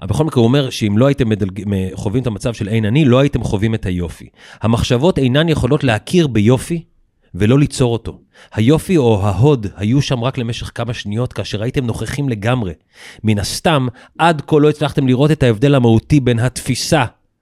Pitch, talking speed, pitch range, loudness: 125 Hz, 180 wpm, 110-140 Hz, -15 LUFS